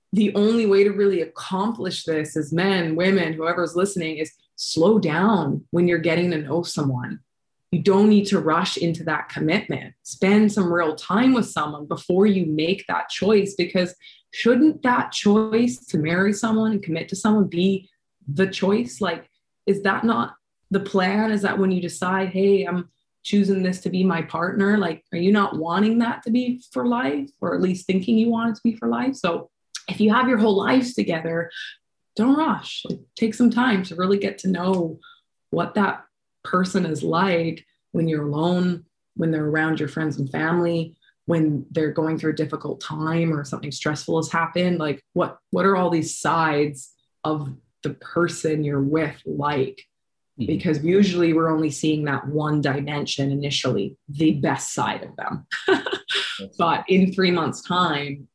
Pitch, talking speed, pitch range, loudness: 175 Hz, 175 wpm, 155-200 Hz, -22 LUFS